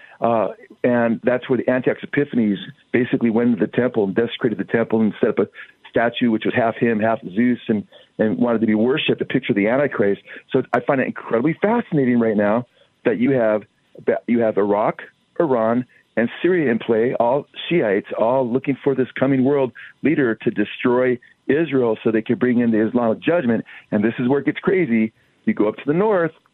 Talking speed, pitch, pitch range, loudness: 205 wpm, 120 Hz, 110-130 Hz, -20 LUFS